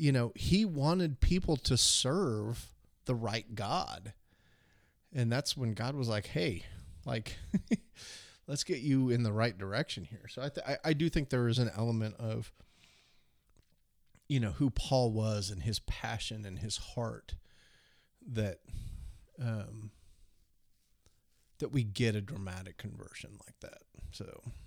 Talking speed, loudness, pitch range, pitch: 140 wpm, -34 LUFS, 100-130 Hz, 115 Hz